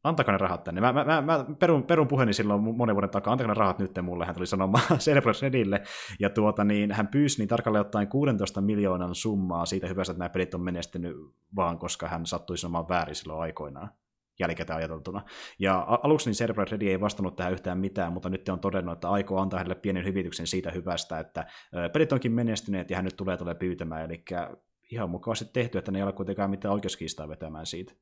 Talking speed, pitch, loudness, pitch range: 210 wpm, 95 Hz, -28 LUFS, 90-110 Hz